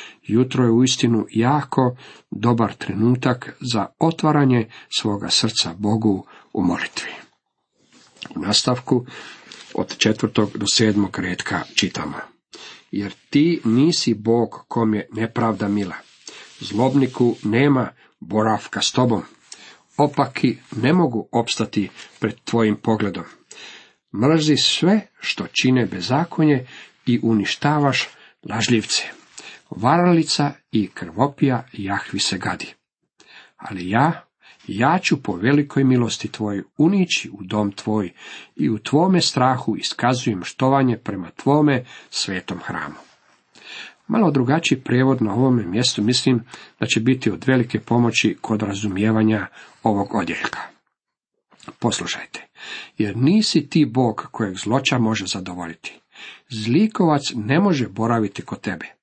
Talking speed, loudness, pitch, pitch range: 110 wpm, -20 LUFS, 120 Hz, 105-135 Hz